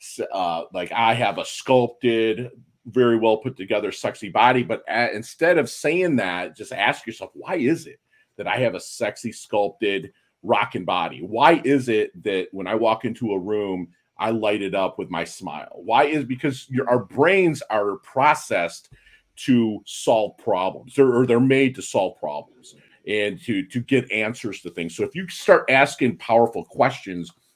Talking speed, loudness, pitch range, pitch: 175 wpm, -22 LUFS, 105-130 Hz, 120 Hz